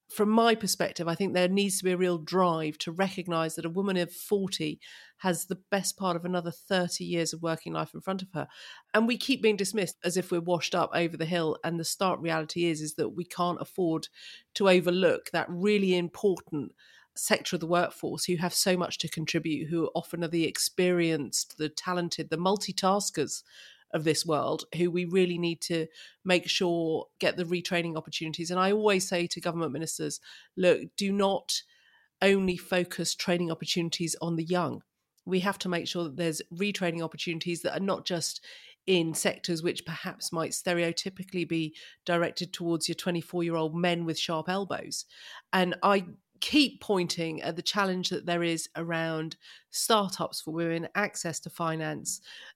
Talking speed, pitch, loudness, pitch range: 180 wpm, 175 Hz, -29 LUFS, 165-190 Hz